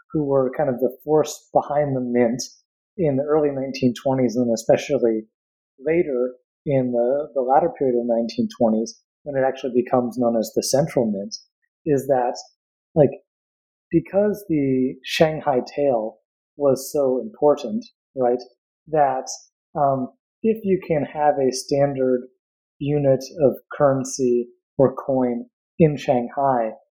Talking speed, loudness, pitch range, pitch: 130 wpm, -21 LUFS, 125-150 Hz, 135 Hz